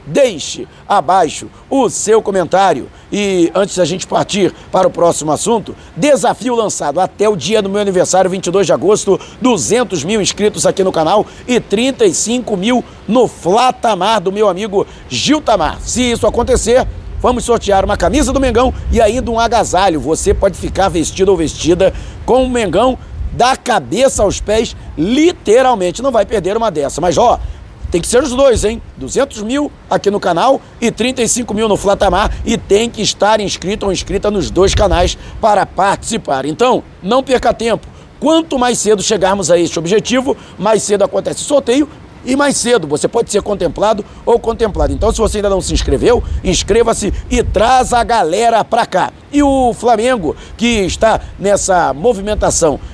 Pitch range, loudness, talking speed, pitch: 190-245 Hz, -13 LUFS, 170 wpm, 215 Hz